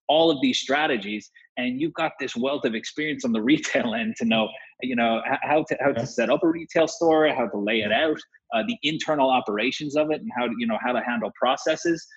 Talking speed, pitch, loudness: 235 wpm, 155 Hz, -24 LUFS